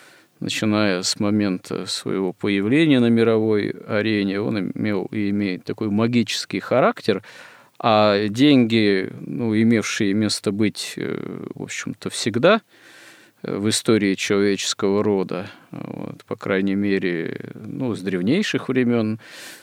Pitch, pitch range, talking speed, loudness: 105 Hz, 100-115 Hz, 115 wpm, -21 LUFS